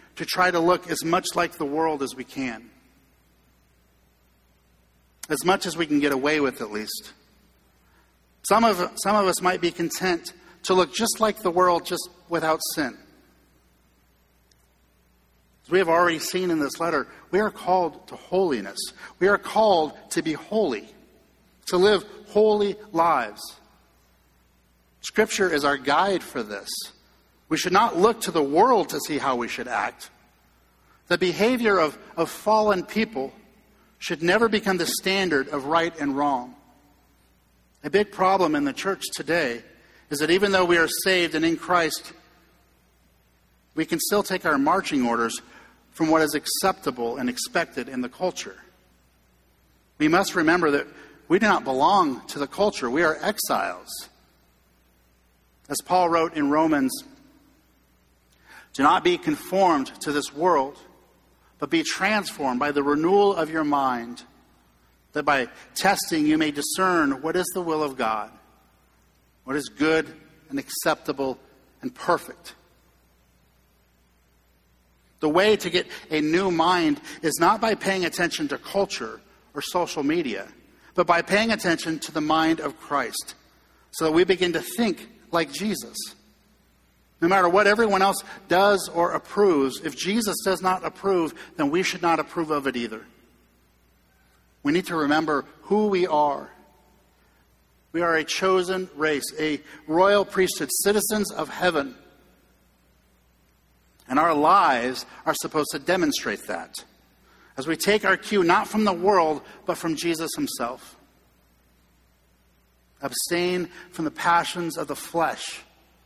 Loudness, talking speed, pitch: -23 LUFS, 145 wpm, 165 Hz